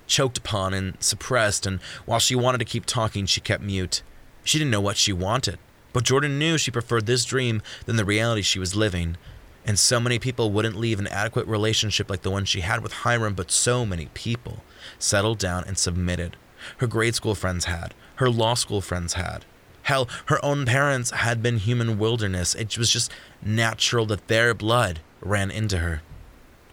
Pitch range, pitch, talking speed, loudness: 95-120 Hz, 110 Hz, 190 wpm, -23 LUFS